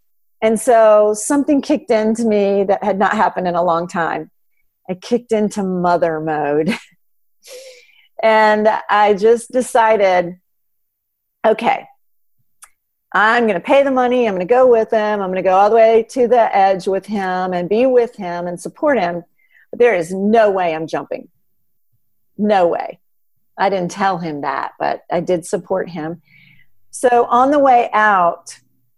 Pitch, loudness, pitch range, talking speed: 205 Hz, -15 LUFS, 175-230 Hz, 155 wpm